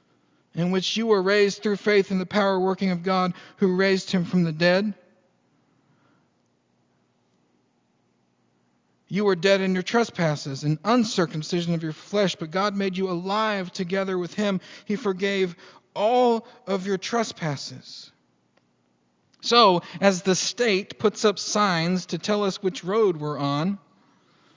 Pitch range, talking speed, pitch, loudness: 165-200 Hz, 140 wpm, 190 Hz, -24 LUFS